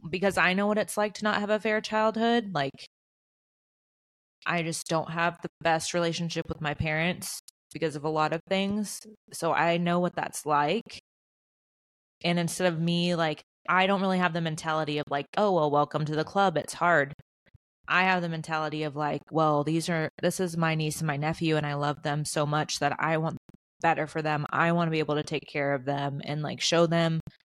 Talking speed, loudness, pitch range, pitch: 215 wpm, -28 LUFS, 150-180 Hz, 165 Hz